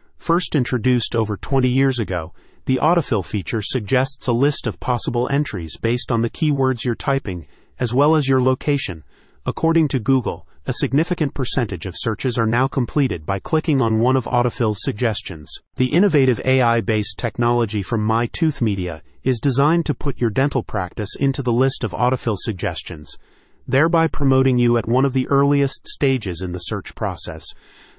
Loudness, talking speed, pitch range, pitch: -20 LUFS, 165 wpm, 110-135 Hz, 125 Hz